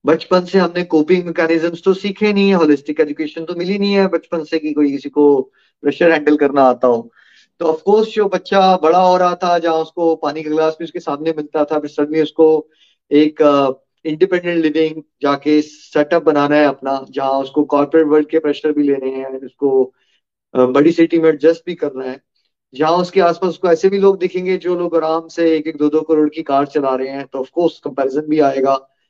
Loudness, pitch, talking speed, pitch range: -15 LUFS, 155 Hz, 205 wpm, 145-170 Hz